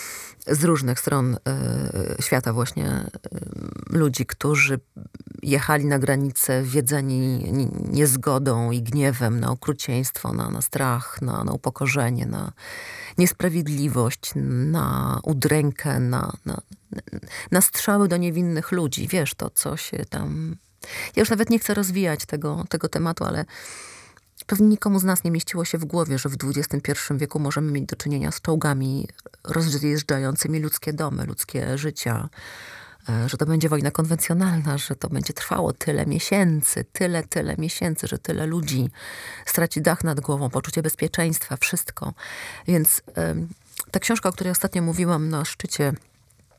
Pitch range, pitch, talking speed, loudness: 130-170 Hz, 150 Hz, 140 wpm, -23 LUFS